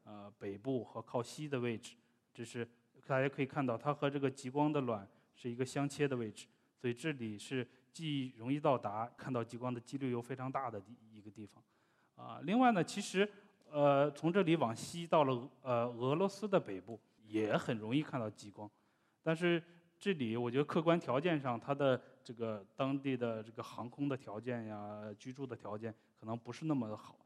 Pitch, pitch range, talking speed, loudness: 125 Hz, 115-145 Hz, 280 characters per minute, -38 LUFS